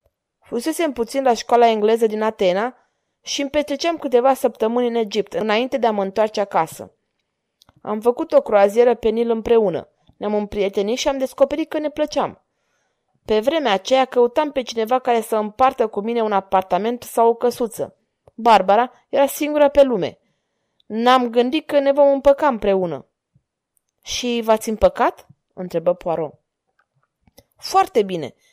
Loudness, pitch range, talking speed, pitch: -19 LUFS, 215-275 Hz, 150 wpm, 235 Hz